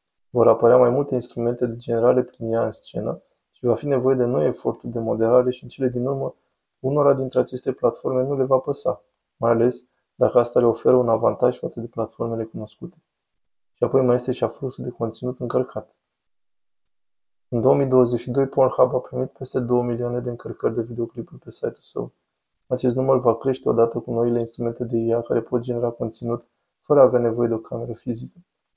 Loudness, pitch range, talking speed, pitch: -22 LUFS, 115-130 Hz, 190 wpm, 125 Hz